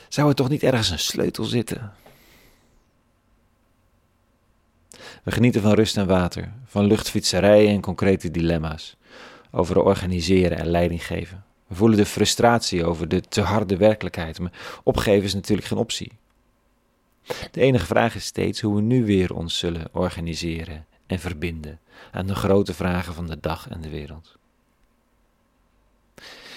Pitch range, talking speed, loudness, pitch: 85-110 Hz, 140 wpm, -22 LUFS, 95 Hz